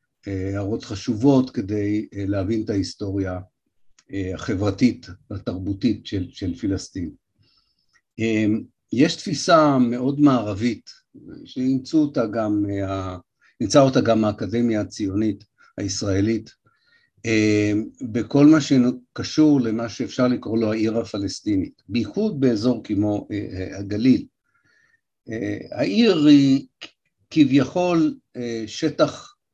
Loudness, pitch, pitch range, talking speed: -21 LUFS, 115 Hz, 105-145 Hz, 95 wpm